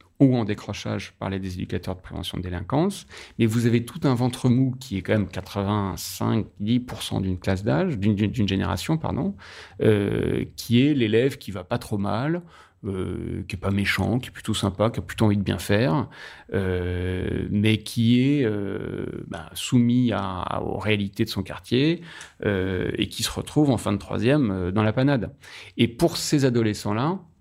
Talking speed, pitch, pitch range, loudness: 190 wpm, 105 Hz, 95-125 Hz, -24 LUFS